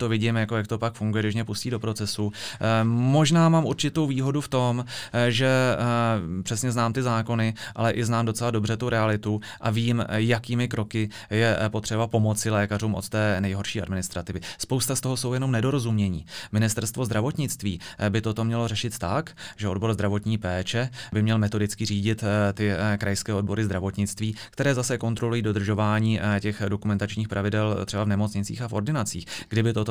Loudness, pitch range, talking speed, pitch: -25 LUFS, 105-120 Hz, 165 wpm, 110 Hz